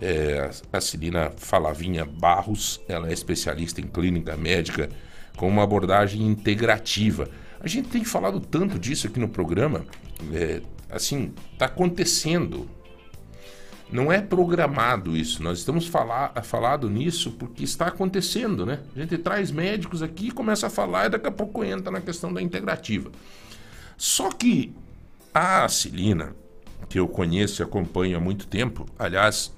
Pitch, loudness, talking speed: 100 Hz, -25 LUFS, 145 wpm